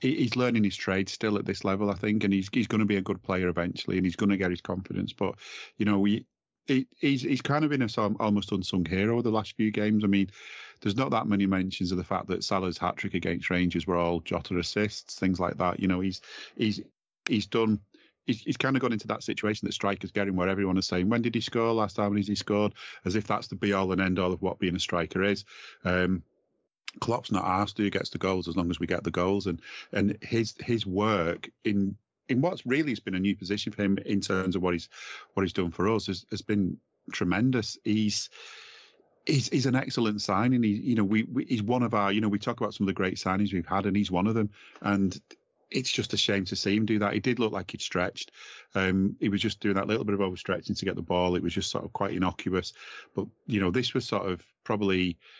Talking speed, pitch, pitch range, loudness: 255 wpm, 100 Hz, 95-110 Hz, -29 LUFS